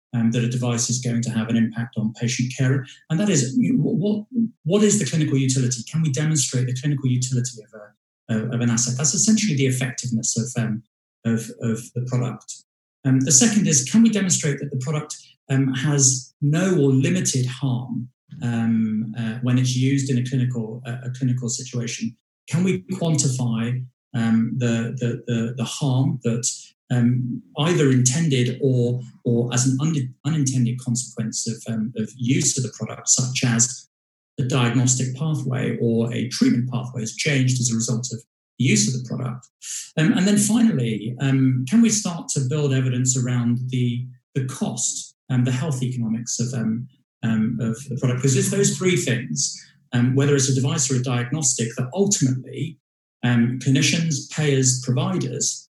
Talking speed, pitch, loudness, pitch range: 175 wpm, 125 Hz, -21 LUFS, 120-140 Hz